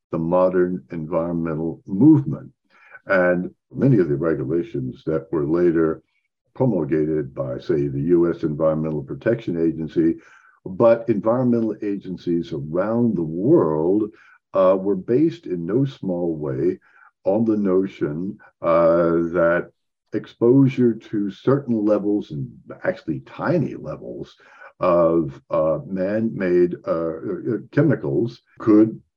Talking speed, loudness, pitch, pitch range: 110 wpm, -21 LUFS, 90 Hz, 80-110 Hz